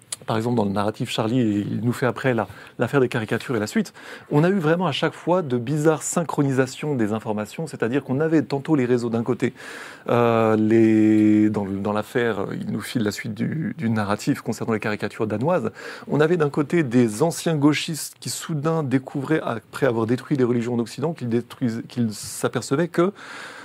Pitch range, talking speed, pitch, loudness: 115-150 Hz, 190 wpm, 125 Hz, -22 LUFS